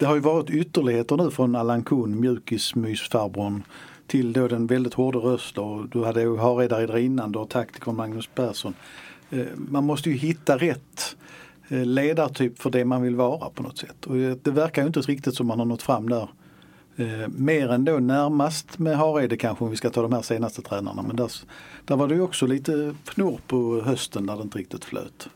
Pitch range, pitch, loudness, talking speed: 115-145 Hz, 125 Hz, -25 LUFS, 195 wpm